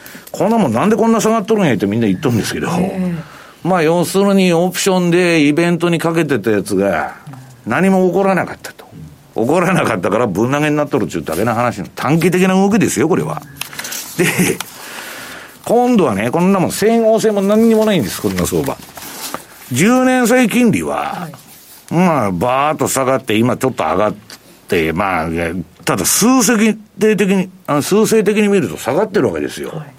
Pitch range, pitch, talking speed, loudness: 130-210 Hz, 180 Hz, 360 characters per minute, -14 LUFS